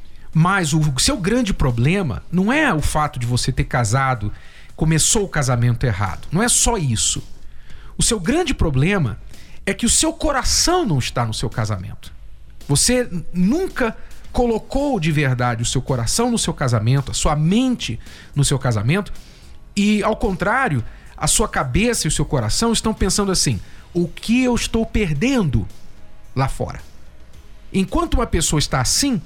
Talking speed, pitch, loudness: 160 wpm, 155 Hz, -19 LUFS